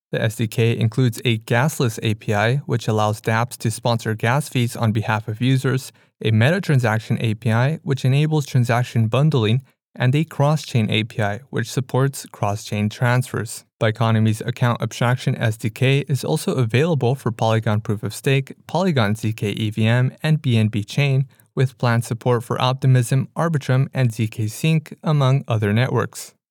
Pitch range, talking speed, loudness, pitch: 110-135 Hz, 145 wpm, -20 LUFS, 120 Hz